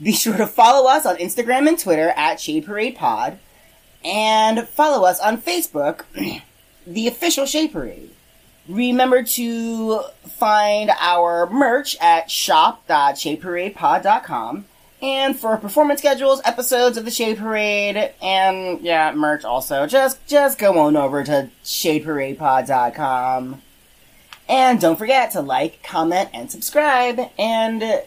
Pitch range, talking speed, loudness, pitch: 180-270 Hz, 125 wpm, -18 LUFS, 225 Hz